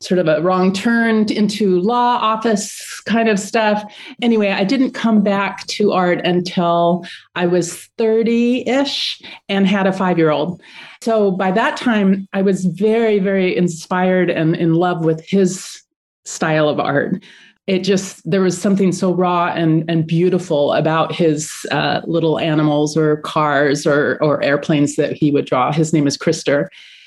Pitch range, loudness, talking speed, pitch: 160-210 Hz, -16 LUFS, 165 wpm, 185 Hz